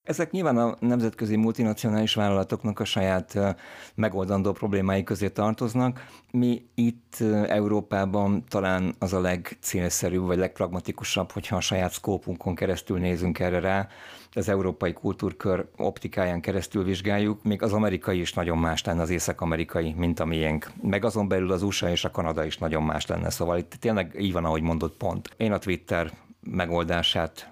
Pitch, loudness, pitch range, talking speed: 95 Hz, -27 LUFS, 90-105 Hz, 155 wpm